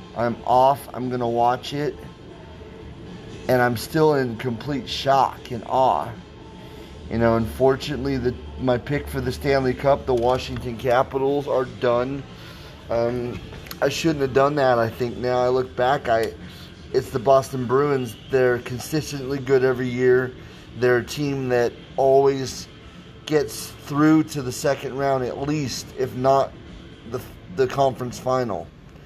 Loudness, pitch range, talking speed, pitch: -22 LUFS, 120-135 Hz, 145 wpm, 130 Hz